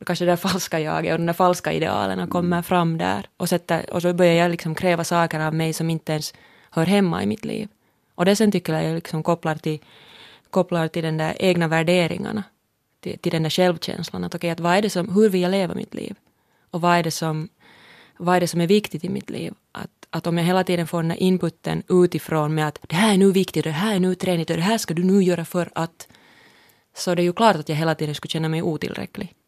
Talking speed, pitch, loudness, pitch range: 245 wpm, 175 Hz, -22 LUFS, 160-185 Hz